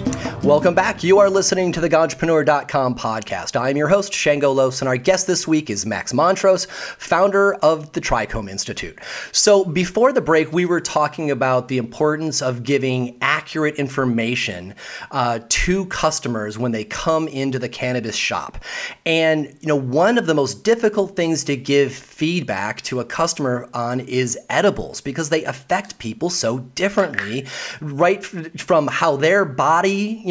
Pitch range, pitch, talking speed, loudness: 130-175 Hz, 150 Hz, 160 wpm, -19 LUFS